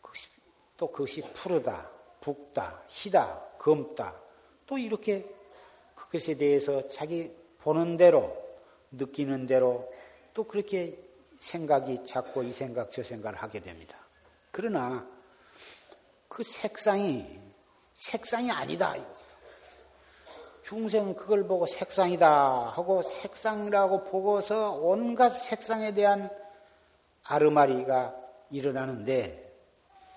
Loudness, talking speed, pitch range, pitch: -29 LUFS, 210 characters per minute, 130-210 Hz, 170 Hz